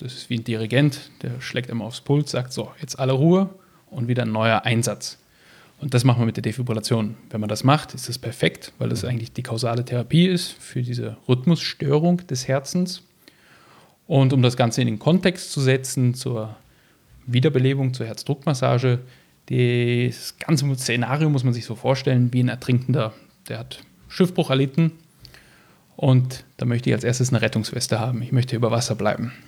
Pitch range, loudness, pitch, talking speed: 120-140 Hz, -22 LUFS, 125 Hz, 180 wpm